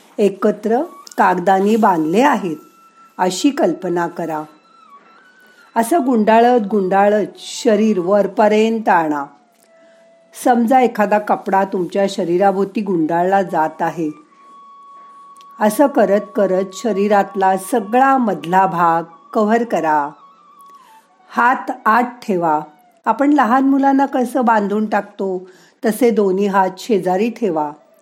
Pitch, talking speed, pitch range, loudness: 215 Hz, 95 wpm, 190-260 Hz, -16 LUFS